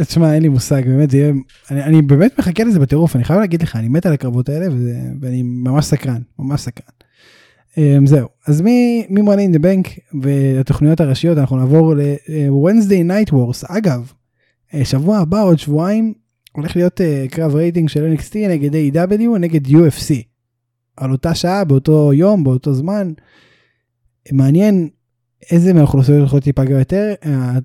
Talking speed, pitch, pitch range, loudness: 155 wpm, 150 Hz, 135-175 Hz, -14 LUFS